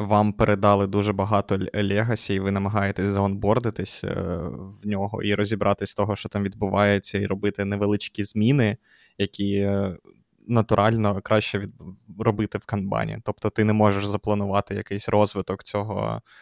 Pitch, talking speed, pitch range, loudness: 100 Hz, 130 wpm, 100-105 Hz, -24 LUFS